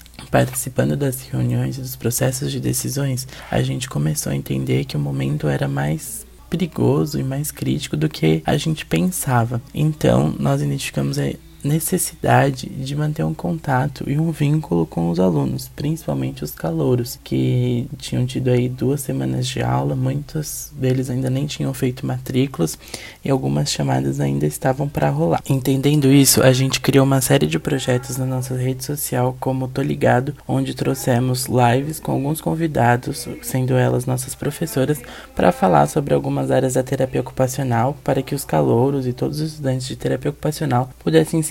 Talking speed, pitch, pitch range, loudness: 165 wpm, 130 Hz, 115-140 Hz, -20 LUFS